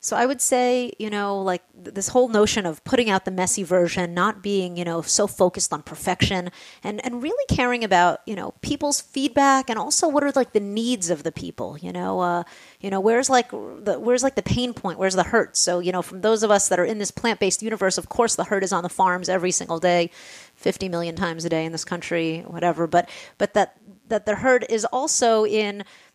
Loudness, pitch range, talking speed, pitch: -22 LUFS, 180-235 Hz, 235 wpm, 200 Hz